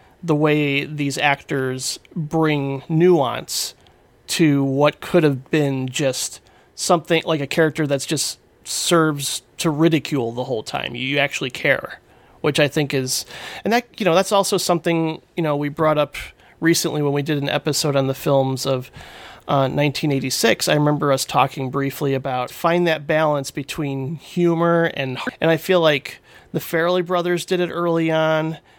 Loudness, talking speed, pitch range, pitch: -20 LUFS, 170 wpm, 140-165 Hz, 150 Hz